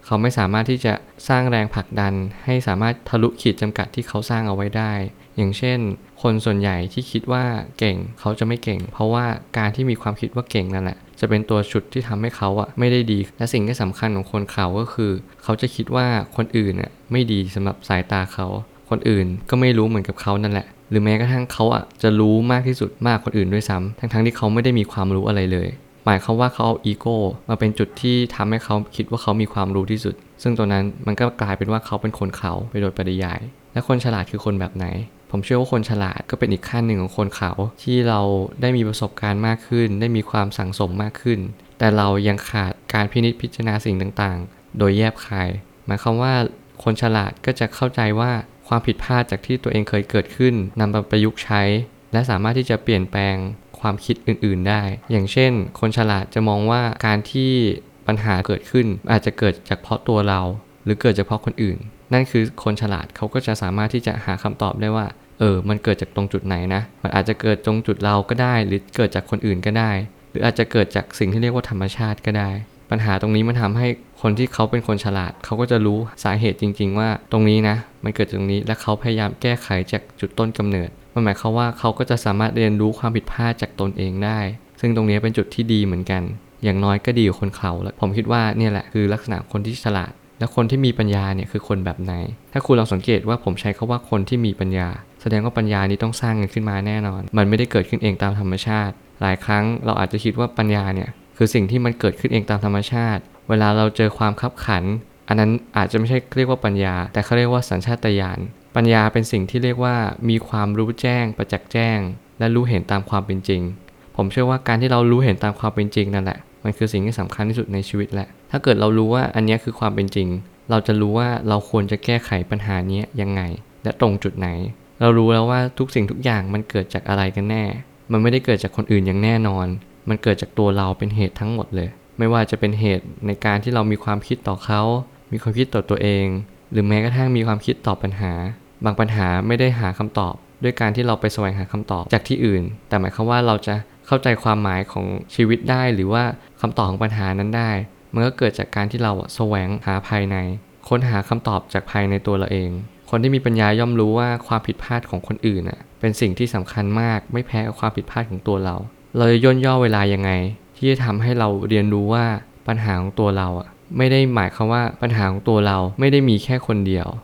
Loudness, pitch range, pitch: -20 LUFS, 100-115 Hz, 110 Hz